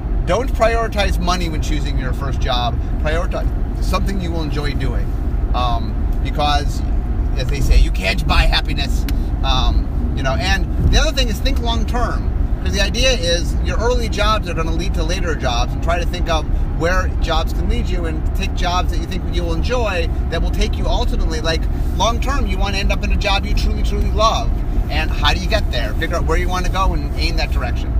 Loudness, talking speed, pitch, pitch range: -19 LUFS, 225 wpm, 70 Hz, 65-80 Hz